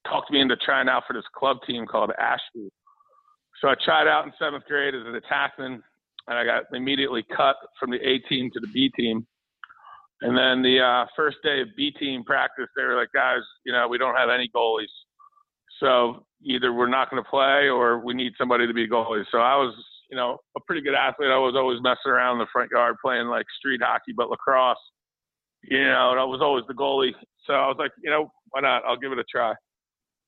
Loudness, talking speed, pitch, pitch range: -23 LUFS, 230 wpm, 130 Hz, 125-170 Hz